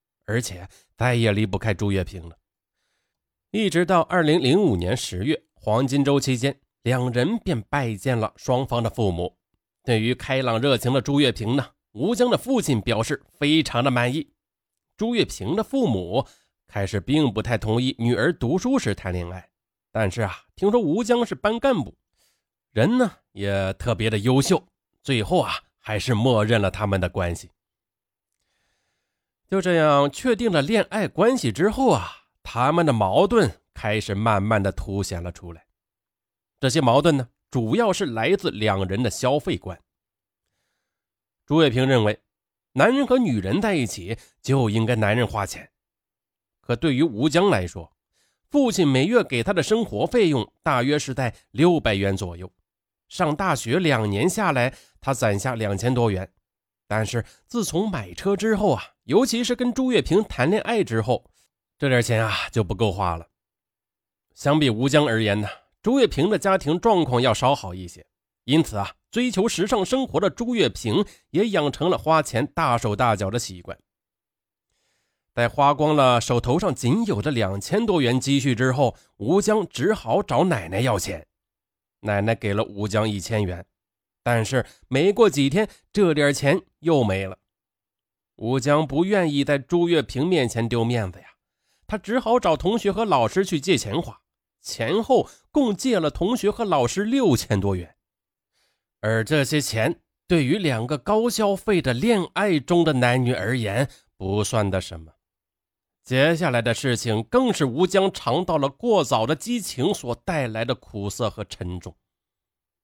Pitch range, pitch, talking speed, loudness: 105-165 Hz, 125 Hz, 230 characters per minute, -22 LUFS